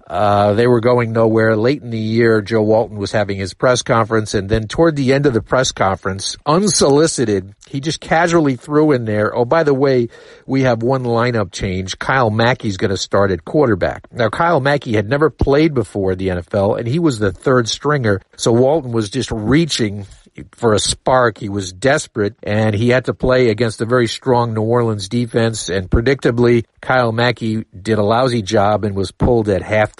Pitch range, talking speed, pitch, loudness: 105-130 Hz, 200 wpm, 115 Hz, -16 LUFS